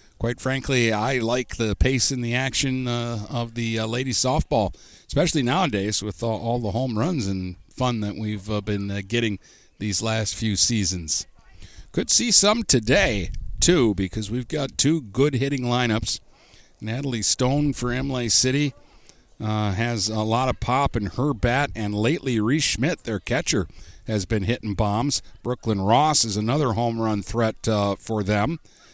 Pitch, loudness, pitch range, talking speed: 115 Hz, -23 LUFS, 105-130 Hz, 170 wpm